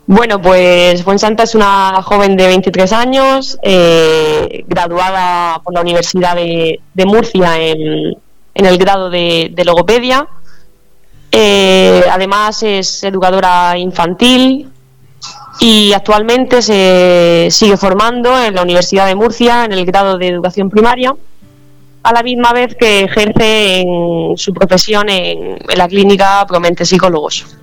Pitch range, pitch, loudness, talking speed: 175-215 Hz, 190 Hz, -9 LUFS, 135 wpm